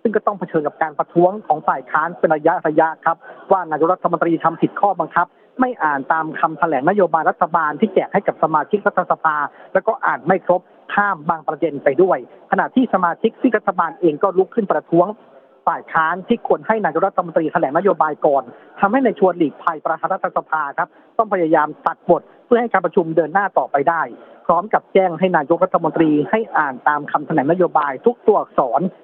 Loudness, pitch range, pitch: -18 LUFS, 160-200 Hz, 175 Hz